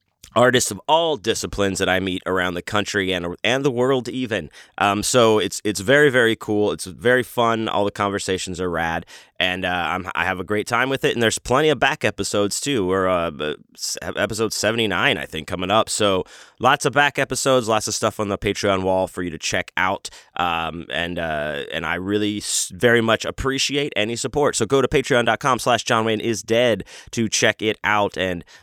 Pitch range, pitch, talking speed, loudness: 95-125 Hz, 105 Hz, 205 wpm, -20 LUFS